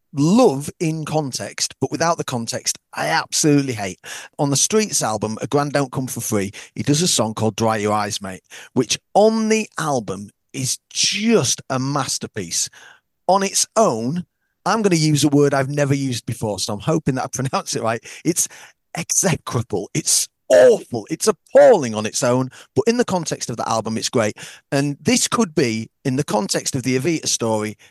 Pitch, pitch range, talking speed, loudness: 140 Hz, 115-165 Hz, 185 wpm, -19 LUFS